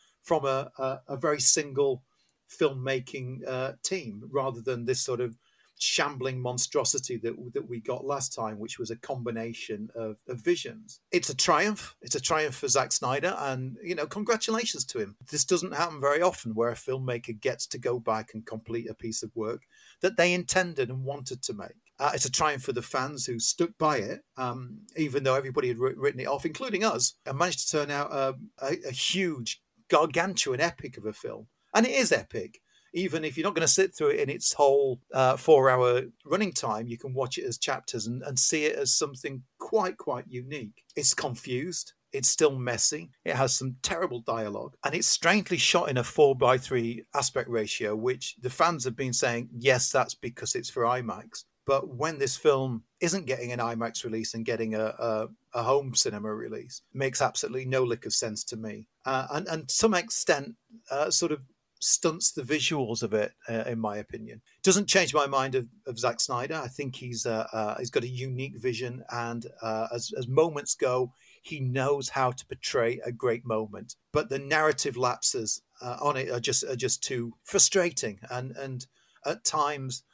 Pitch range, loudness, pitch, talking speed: 120-155 Hz, -28 LUFS, 130 Hz, 200 wpm